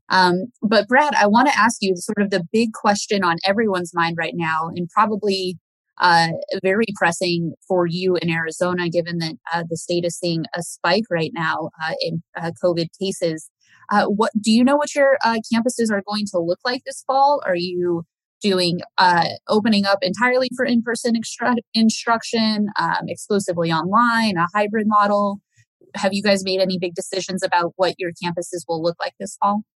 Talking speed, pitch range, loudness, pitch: 190 wpm, 175-220 Hz, -20 LUFS, 190 Hz